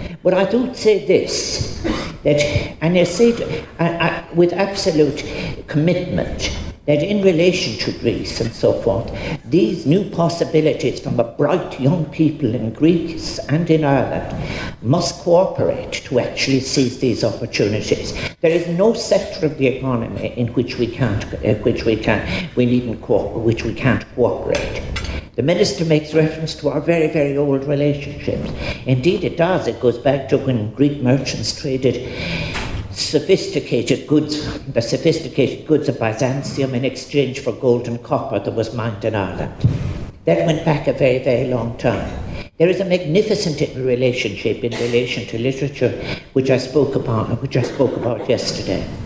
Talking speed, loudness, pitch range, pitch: 160 wpm, -19 LUFS, 120-165 Hz, 140 Hz